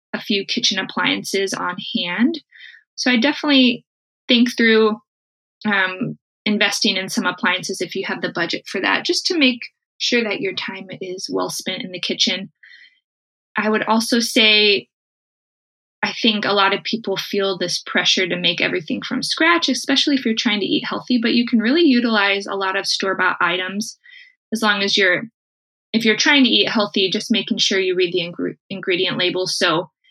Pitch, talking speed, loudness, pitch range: 215 Hz, 180 wpm, -18 LUFS, 195-250 Hz